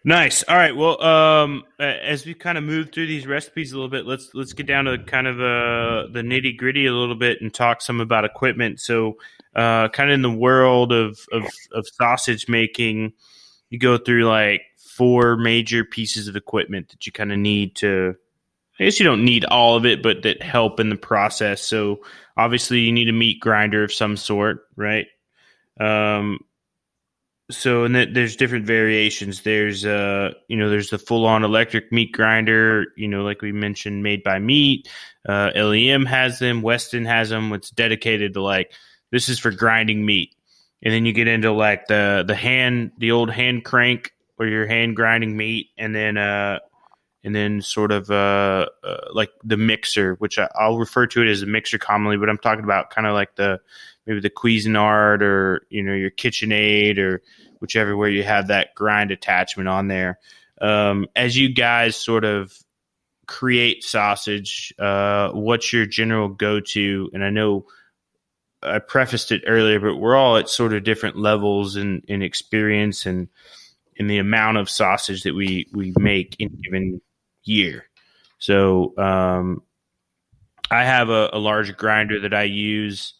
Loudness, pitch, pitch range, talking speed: -19 LUFS, 110 Hz, 105-120 Hz, 180 wpm